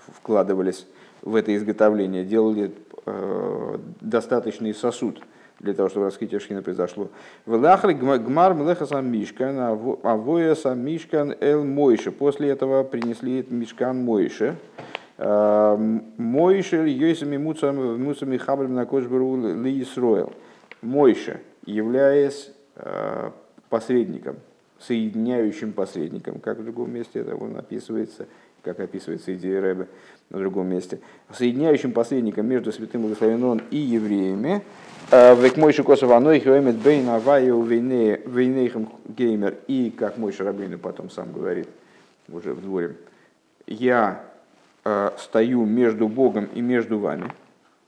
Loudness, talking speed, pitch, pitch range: -22 LUFS, 100 wpm, 120 Hz, 110-135 Hz